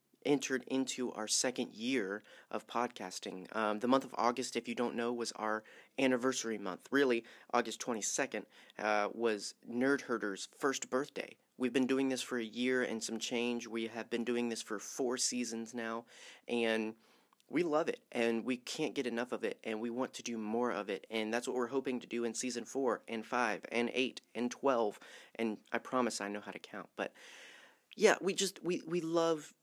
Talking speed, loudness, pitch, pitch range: 200 wpm, -36 LUFS, 120 Hz, 110-130 Hz